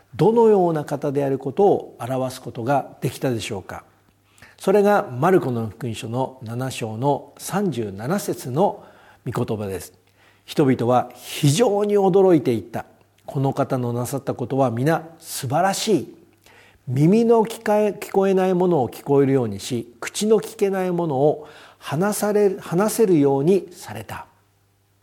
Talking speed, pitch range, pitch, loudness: 275 characters per minute, 115-185 Hz, 135 Hz, -21 LUFS